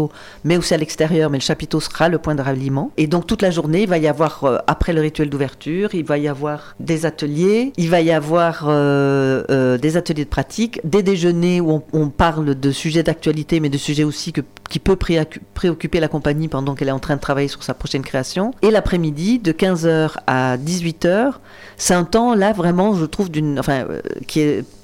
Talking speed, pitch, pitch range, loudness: 215 wpm, 155 Hz, 145-175 Hz, -18 LUFS